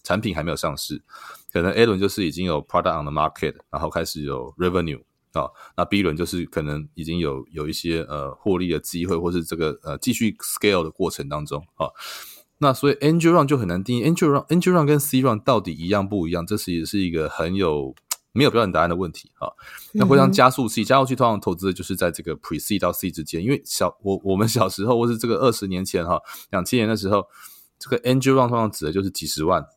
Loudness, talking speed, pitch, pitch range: -22 LUFS, 440 characters per minute, 95 Hz, 85-120 Hz